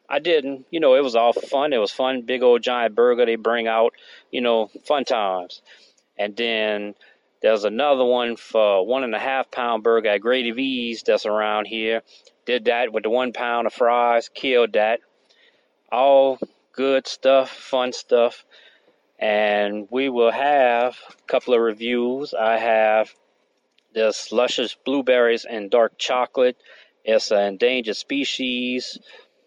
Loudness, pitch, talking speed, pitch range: -21 LUFS, 125 Hz, 155 wpm, 115-140 Hz